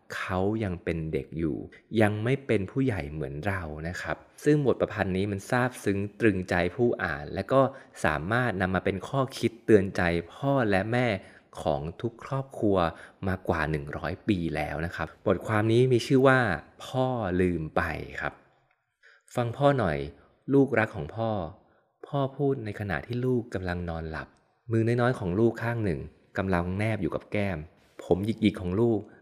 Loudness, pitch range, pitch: -28 LUFS, 85-120 Hz, 100 Hz